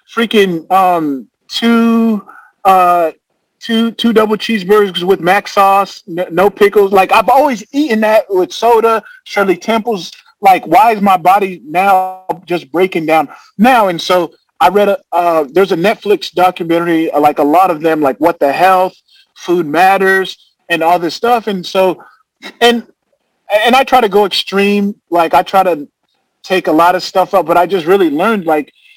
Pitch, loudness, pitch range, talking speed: 195 Hz, -11 LUFS, 175-225 Hz, 170 wpm